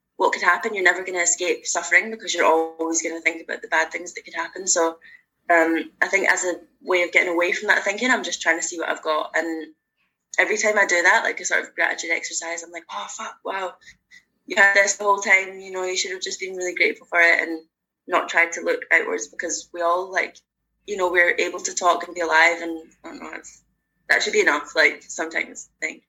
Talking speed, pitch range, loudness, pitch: 250 wpm, 165-195 Hz, -20 LUFS, 175 Hz